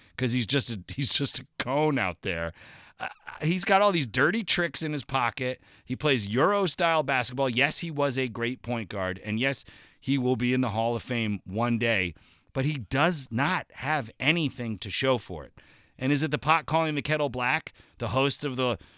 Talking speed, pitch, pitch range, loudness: 210 wpm, 130 Hz, 115-145 Hz, -27 LUFS